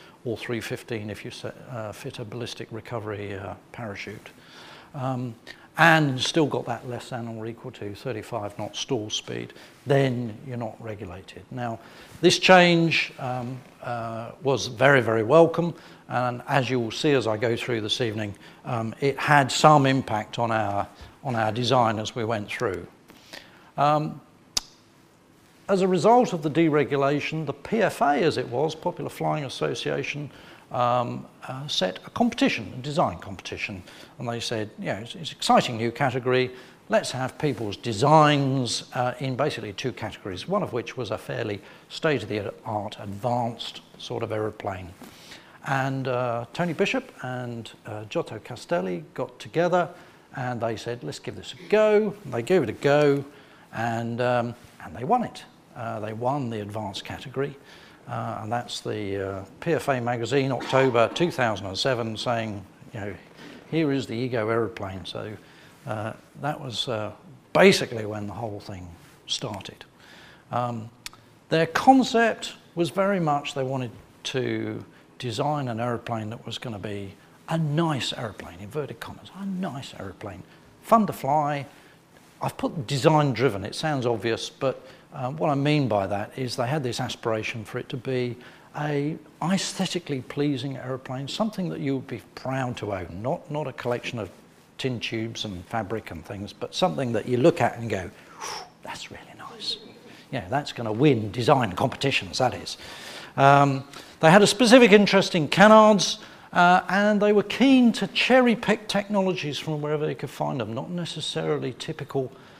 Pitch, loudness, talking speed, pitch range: 130 Hz, -25 LUFS, 165 wpm, 115-150 Hz